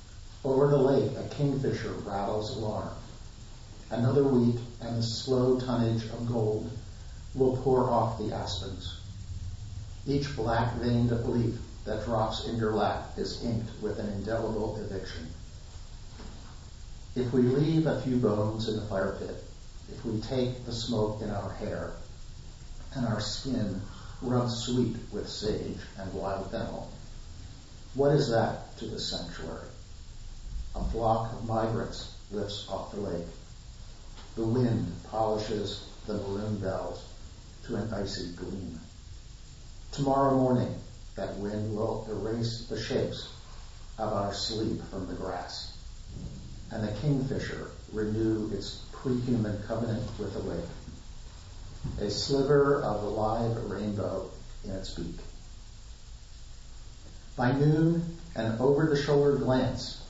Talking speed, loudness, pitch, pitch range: 125 wpm, -31 LUFS, 110 Hz, 100-120 Hz